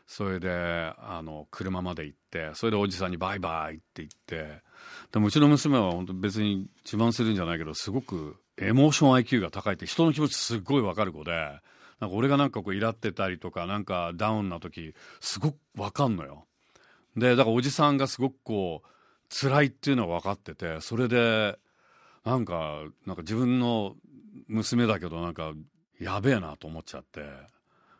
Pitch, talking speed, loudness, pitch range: 100 Hz, 365 characters per minute, -28 LUFS, 85-120 Hz